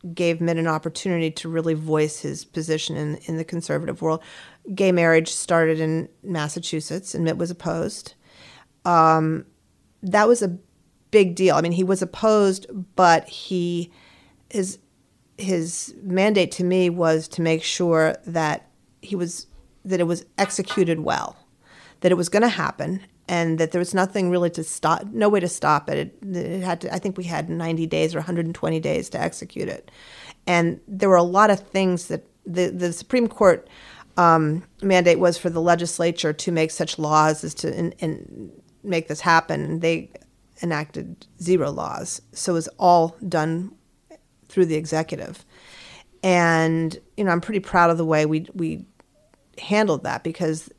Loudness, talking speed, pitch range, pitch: -22 LUFS, 170 wpm, 160-185 Hz, 170 Hz